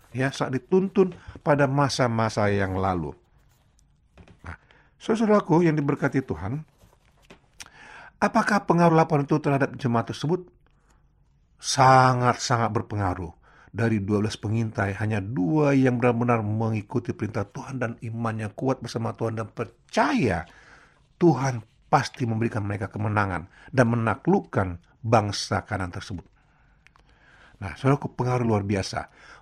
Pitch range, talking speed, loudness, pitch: 105-140 Hz, 110 wpm, -24 LUFS, 120 Hz